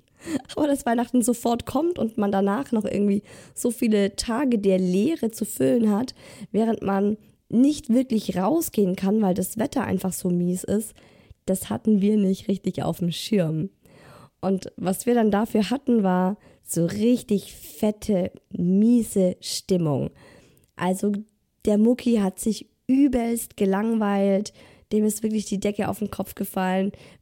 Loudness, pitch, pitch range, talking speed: -24 LUFS, 205 Hz, 190-230 Hz, 150 wpm